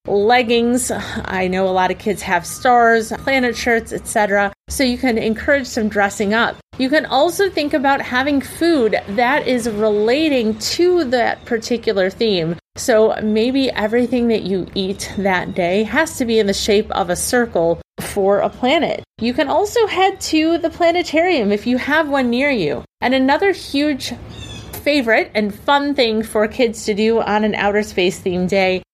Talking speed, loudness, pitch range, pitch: 170 wpm, -17 LUFS, 205-275 Hz, 230 Hz